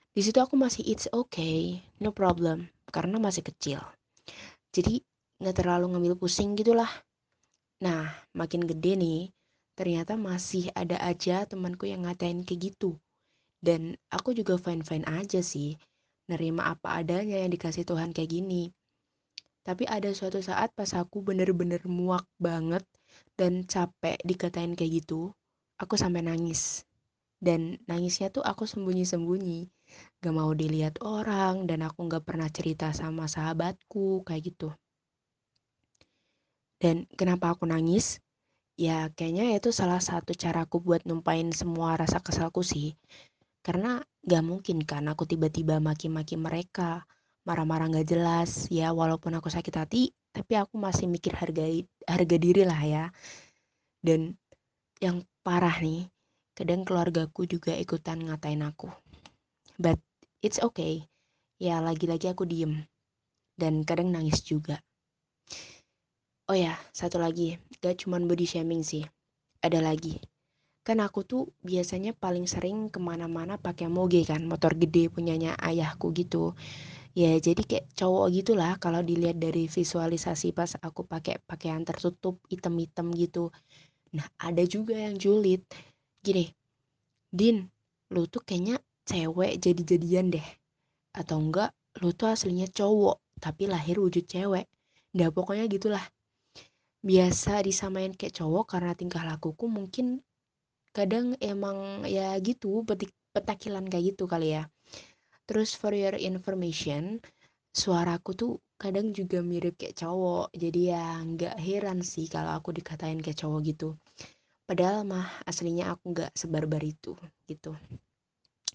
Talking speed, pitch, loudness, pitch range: 130 wpm, 175 Hz, -30 LUFS, 165-190 Hz